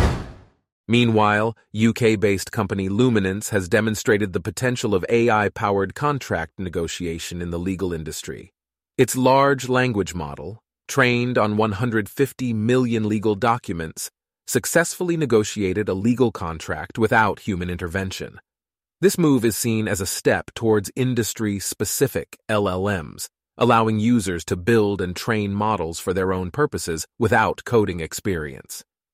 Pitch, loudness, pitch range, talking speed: 105 Hz, -21 LUFS, 95-120 Hz, 125 wpm